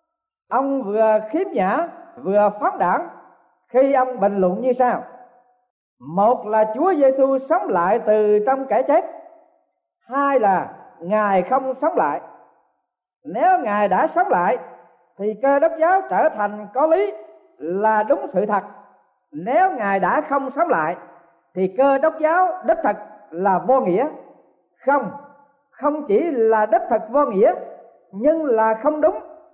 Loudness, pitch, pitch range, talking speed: -19 LUFS, 260 Hz, 210-315 Hz, 150 wpm